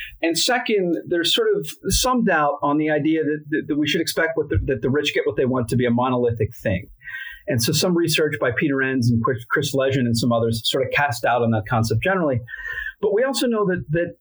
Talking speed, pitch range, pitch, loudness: 240 wpm, 125-185 Hz, 150 Hz, -21 LUFS